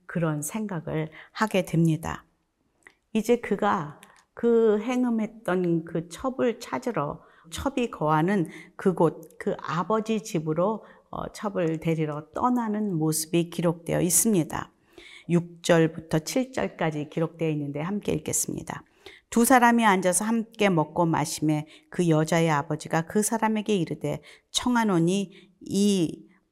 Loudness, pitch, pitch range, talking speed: -26 LUFS, 180 Hz, 160-220 Hz, 255 characters per minute